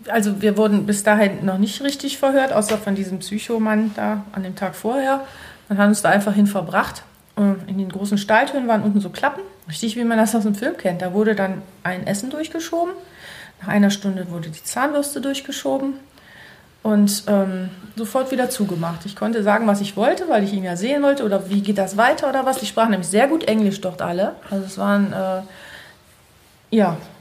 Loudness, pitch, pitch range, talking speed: -20 LUFS, 210 Hz, 195-250 Hz, 205 wpm